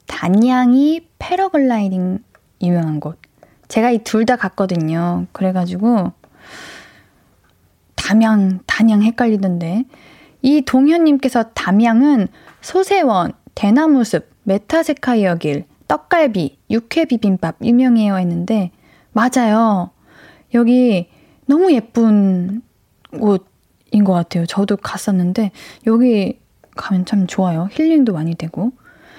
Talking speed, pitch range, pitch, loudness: 225 characters per minute, 180-250 Hz, 215 Hz, -16 LUFS